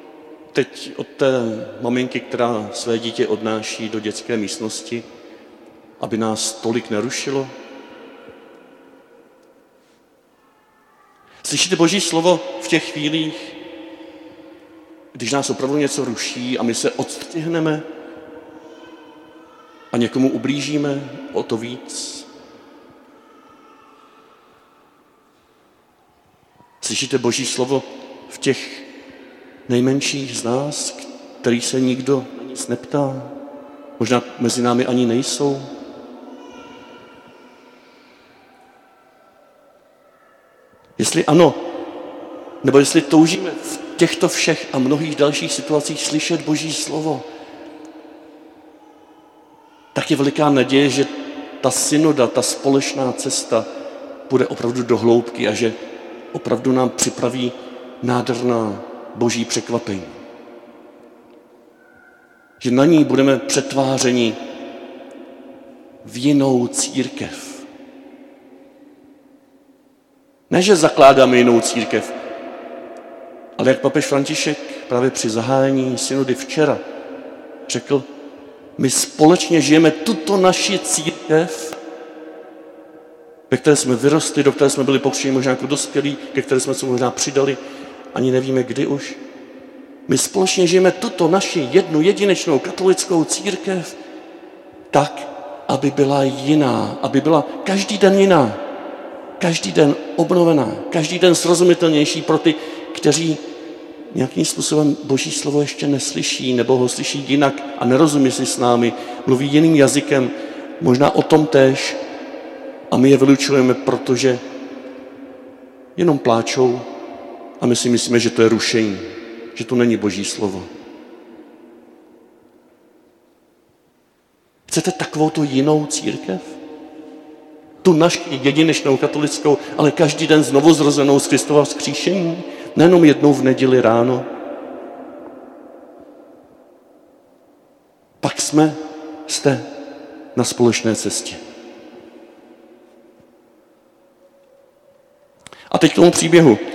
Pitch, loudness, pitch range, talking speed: 145 Hz, -17 LUFS, 125-160 Hz, 100 wpm